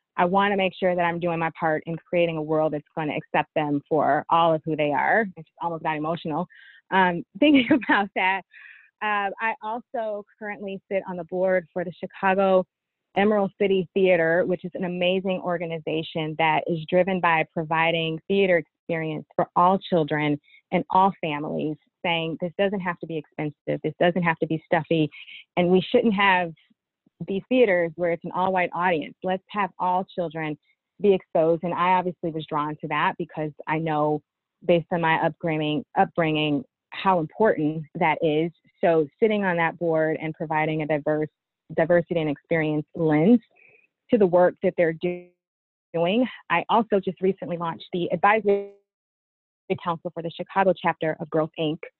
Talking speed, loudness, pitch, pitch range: 170 wpm, -24 LUFS, 175 Hz, 160-190 Hz